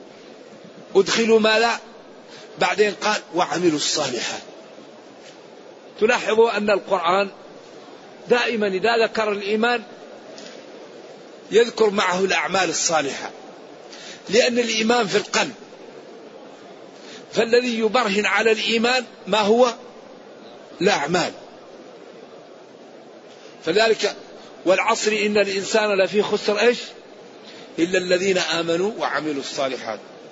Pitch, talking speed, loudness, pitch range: 220 Hz, 85 wpm, -20 LUFS, 200-240 Hz